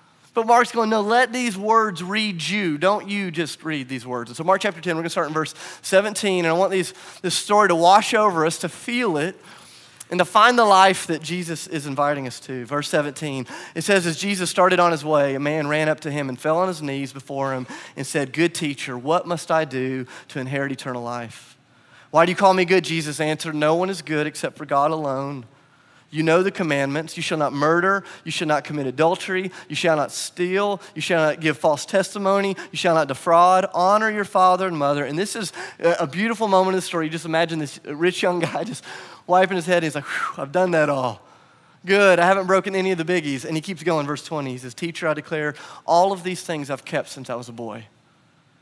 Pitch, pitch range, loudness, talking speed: 165 Hz, 145-185 Hz, -21 LUFS, 235 wpm